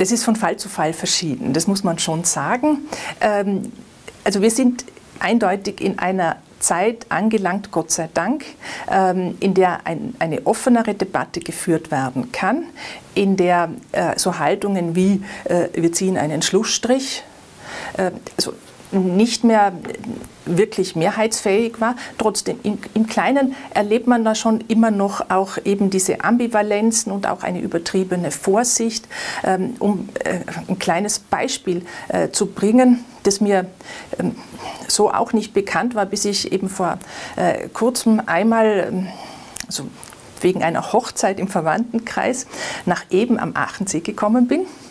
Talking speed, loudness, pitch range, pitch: 125 wpm, -19 LUFS, 185-230 Hz, 205 Hz